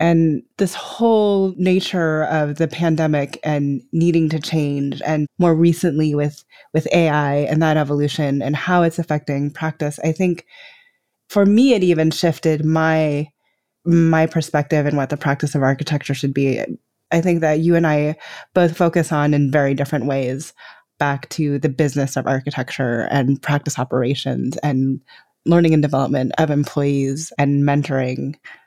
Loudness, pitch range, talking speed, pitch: -18 LUFS, 140-165 Hz, 155 wpm, 150 Hz